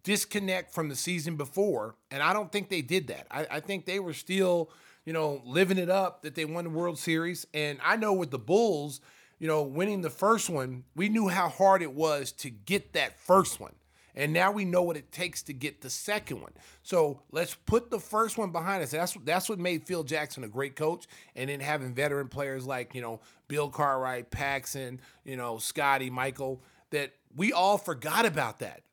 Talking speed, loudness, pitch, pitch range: 210 wpm, -30 LUFS, 155 Hz, 135-185 Hz